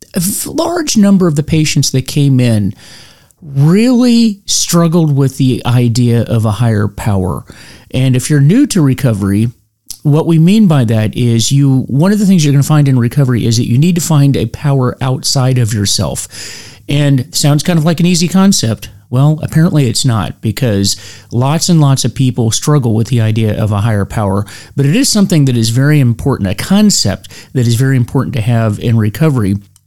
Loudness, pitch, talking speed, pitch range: -11 LUFS, 130 Hz, 195 wpm, 115-155 Hz